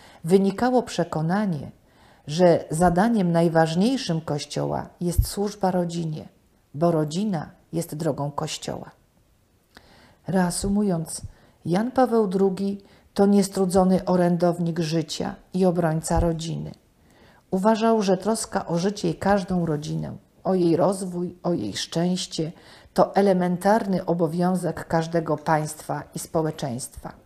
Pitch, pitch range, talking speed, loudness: 175 Hz, 160-195 Hz, 100 wpm, -24 LUFS